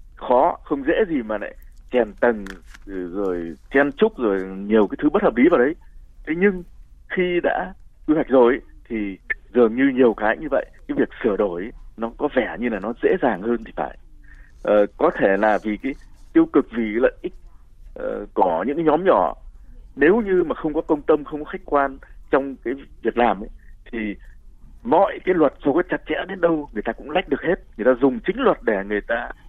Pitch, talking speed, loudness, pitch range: 130 Hz, 220 wpm, -21 LUFS, 105-165 Hz